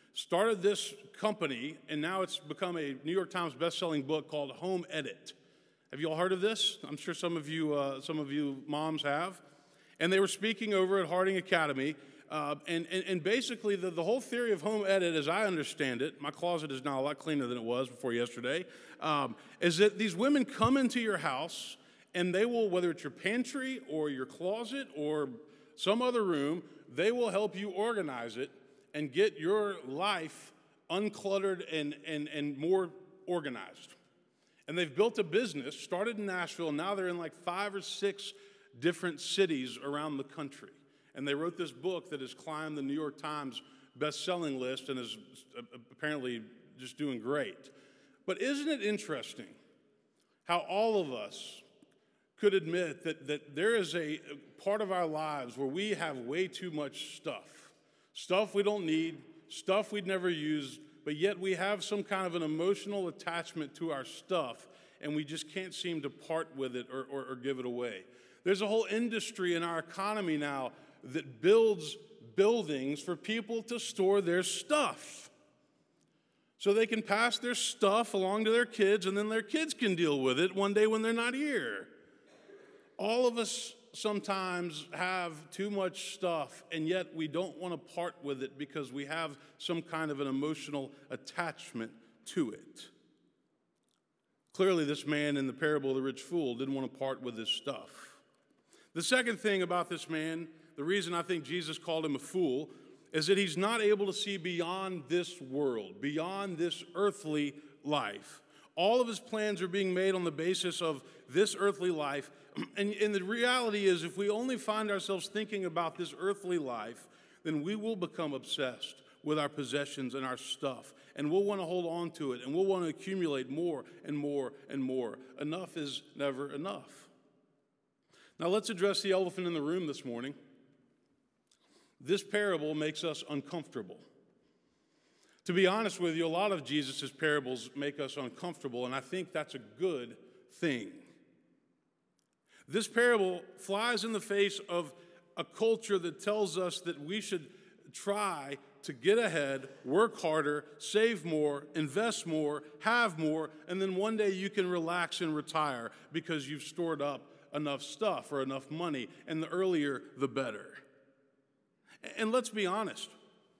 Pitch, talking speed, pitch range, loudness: 170 Hz, 175 wpm, 145-200 Hz, -34 LUFS